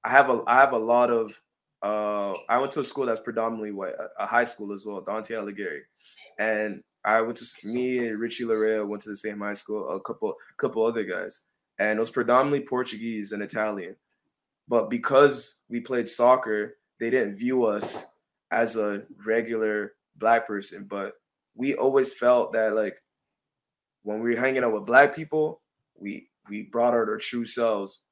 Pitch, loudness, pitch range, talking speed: 115 Hz, -26 LUFS, 105-120 Hz, 180 wpm